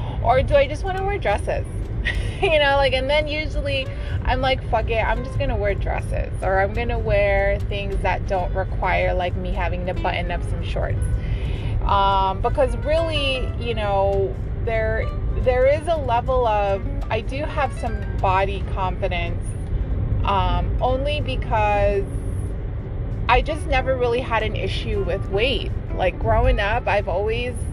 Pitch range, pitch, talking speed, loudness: 95-115 Hz, 100 Hz, 160 wpm, -22 LUFS